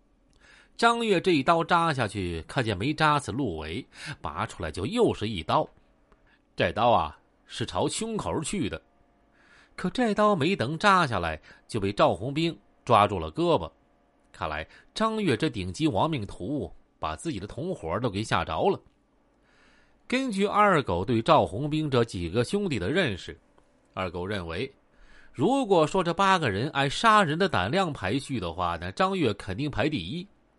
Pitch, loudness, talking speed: 150 Hz, -26 LUFS, 230 characters per minute